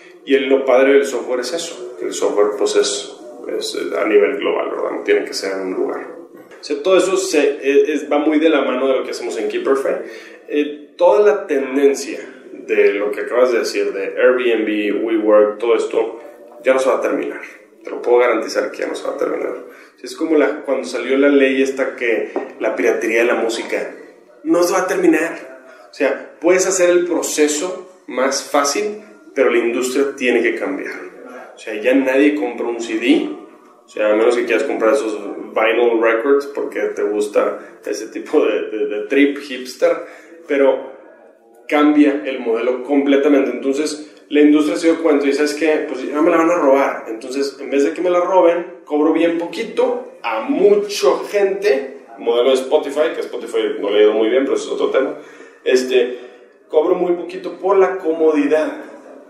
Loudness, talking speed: -17 LUFS, 195 wpm